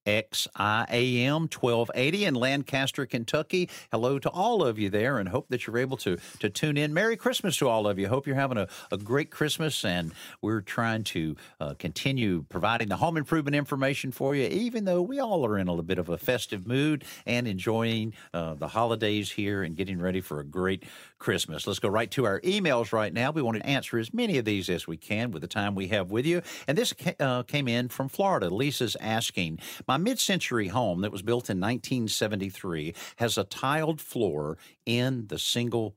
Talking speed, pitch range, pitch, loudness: 210 wpm, 100-140 Hz, 120 Hz, -28 LUFS